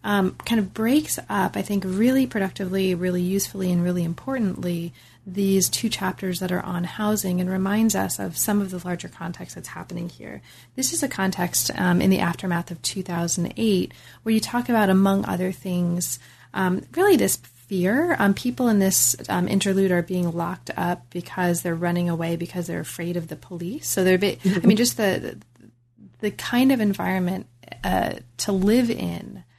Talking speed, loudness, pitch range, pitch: 185 wpm, -23 LUFS, 175-205 Hz, 185 Hz